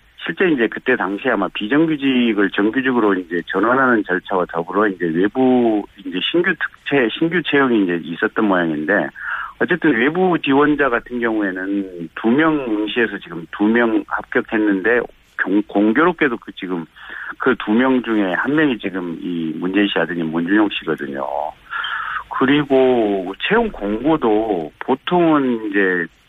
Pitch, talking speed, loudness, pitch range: 105 Hz, 300 characters per minute, -18 LUFS, 95-130 Hz